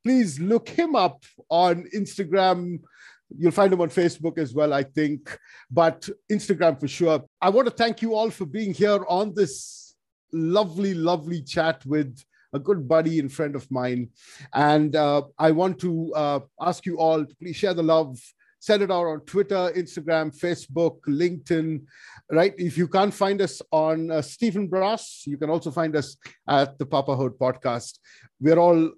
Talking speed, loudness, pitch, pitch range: 175 wpm, -24 LUFS, 165 Hz, 150-190 Hz